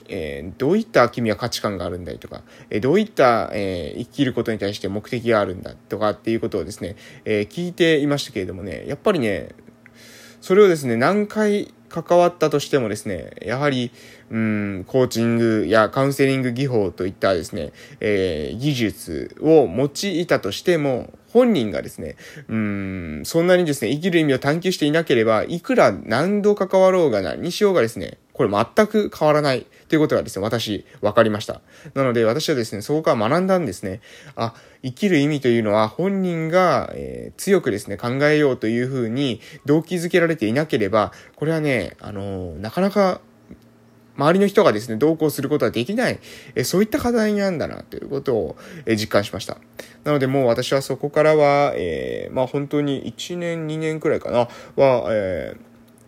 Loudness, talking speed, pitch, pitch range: -20 LUFS, 380 characters per minute, 140 Hz, 115-170 Hz